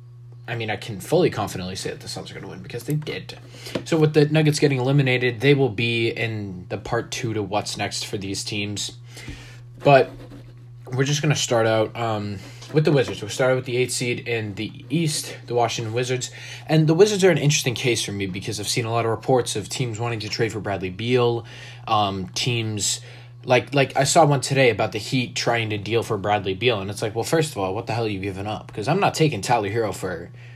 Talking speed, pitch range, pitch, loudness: 240 wpm, 110-130 Hz, 120 Hz, -22 LUFS